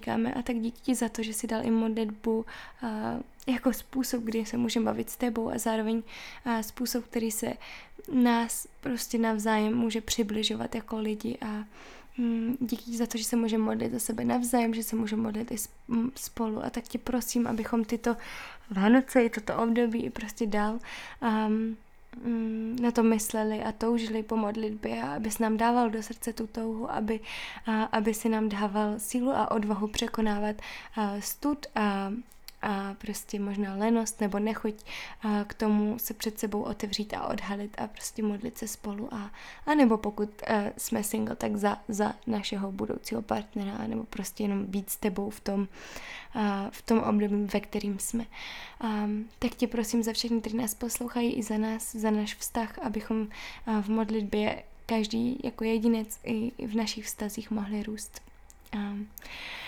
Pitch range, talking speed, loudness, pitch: 215-235 Hz, 170 wpm, -30 LUFS, 225 Hz